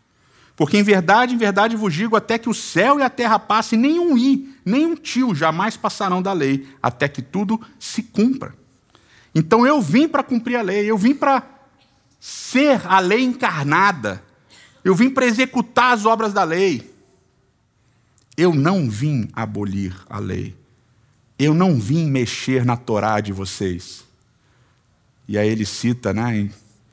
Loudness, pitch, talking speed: -18 LUFS, 160 Hz, 155 wpm